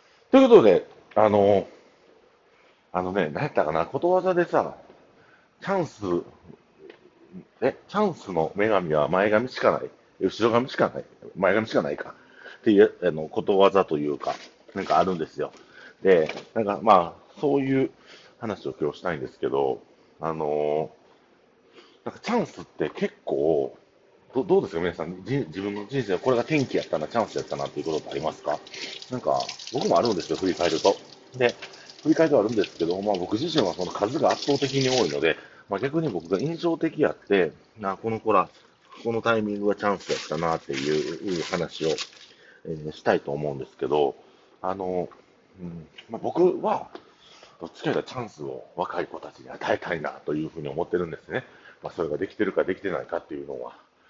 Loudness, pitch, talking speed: -25 LUFS, 120 Hz, 355 characters per minute